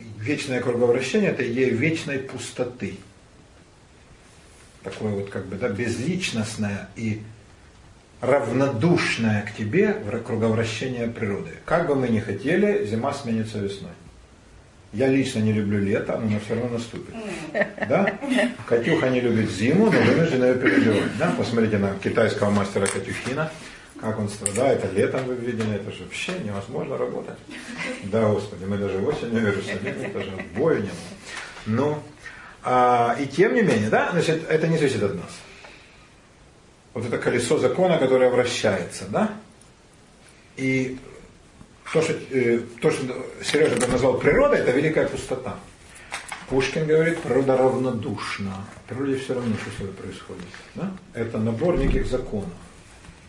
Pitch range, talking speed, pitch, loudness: 105-130 Hz, 135 wpm, 115 Hz, -23 LUFS